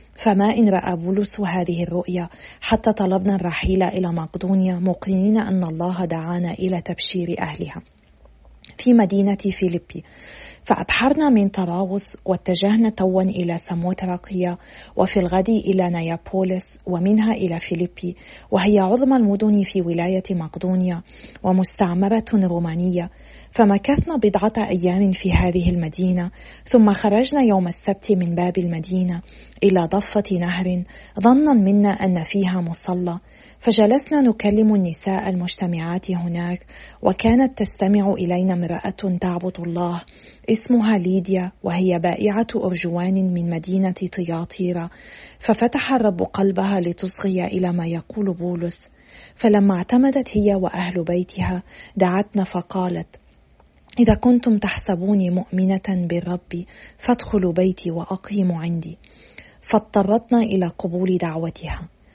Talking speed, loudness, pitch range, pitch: 105 wpm, -20 LUFS, 175-205 Hz, 185 Hz